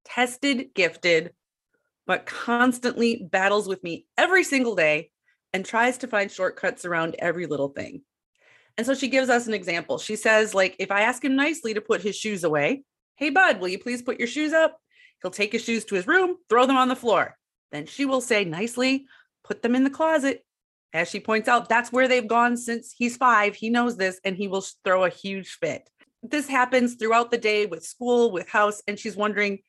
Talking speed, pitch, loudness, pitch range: 210 wpm, 235 Hz, -23 LUFS, 200-255 Hz